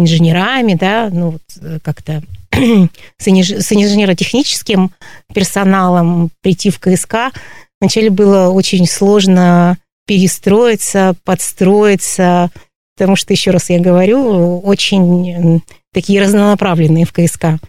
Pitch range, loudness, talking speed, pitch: 175-200 Hz, -11 LUFS, 100 wpm, 185 Hz